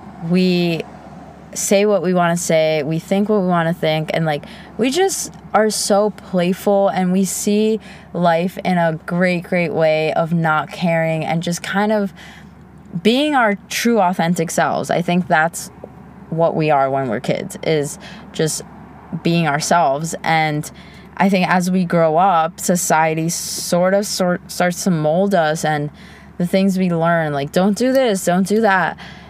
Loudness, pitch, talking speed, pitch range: -17 LUFS, 180 Hz, 170 wpm, 165-195 Hz